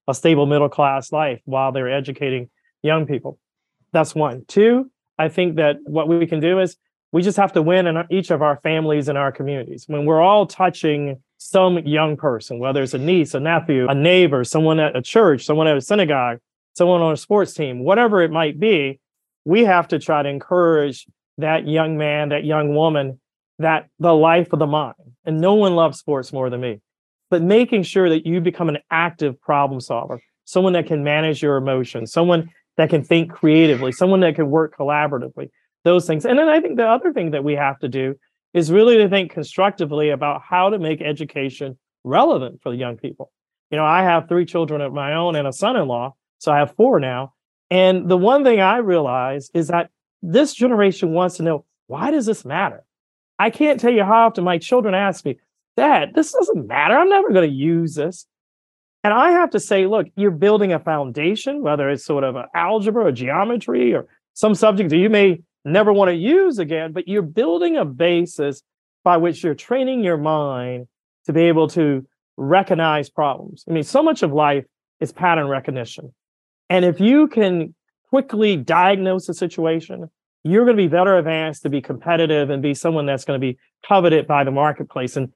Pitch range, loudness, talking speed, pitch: 145-185 Hz, -18 LUFS, 200 wpm, 160 Hz